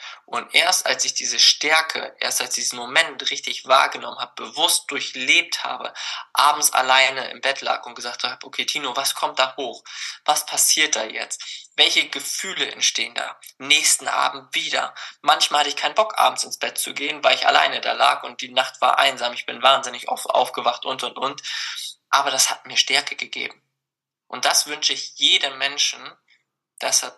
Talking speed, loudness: 185 wpm, -19 LUFS